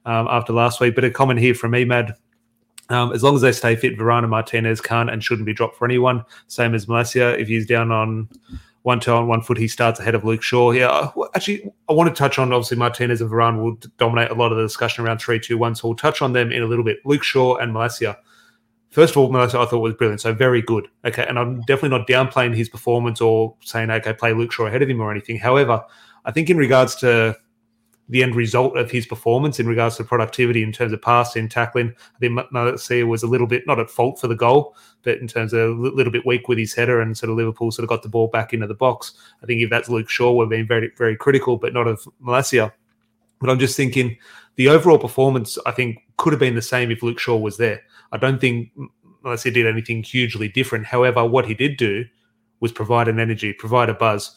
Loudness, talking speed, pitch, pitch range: -19 LUFS, 245 wpm, 120 Hz, 115-125 Hz